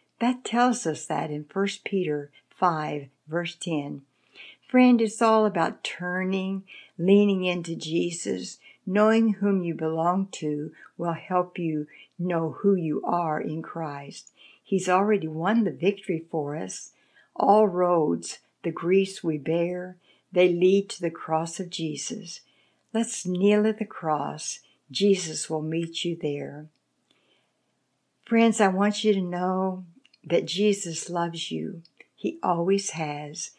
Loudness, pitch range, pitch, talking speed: -26 LUFS, 160-200 Hz, 180 Hz, 135 wpm